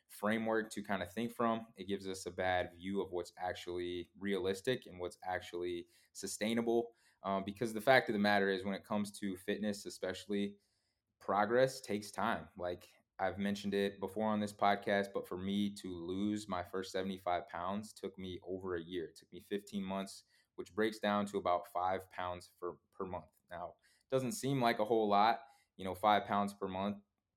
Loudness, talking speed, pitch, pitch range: -38 LUFS, 195 wpm, 100 Hz, 95-105 Hz